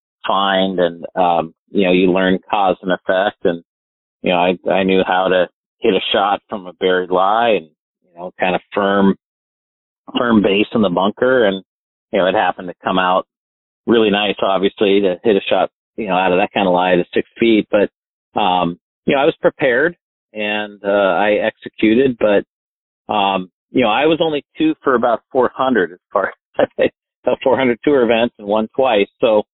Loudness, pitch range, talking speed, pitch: -16 LUFS, 90-105 Hz, 190 wpm, 95 Hz